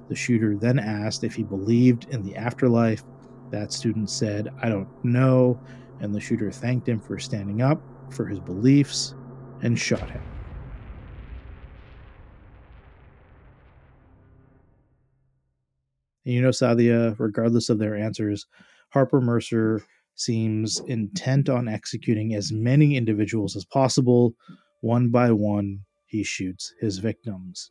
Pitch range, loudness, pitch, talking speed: 105-130 Hz, -24 LUFS, 115 Hz, 120 wpm